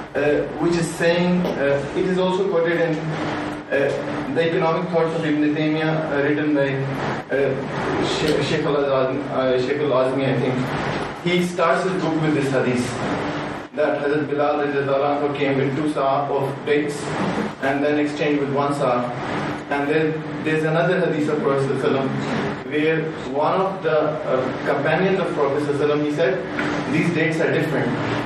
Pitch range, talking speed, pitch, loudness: 140-160 Hz, 150 wpm, 150 Hz, -21 LUFS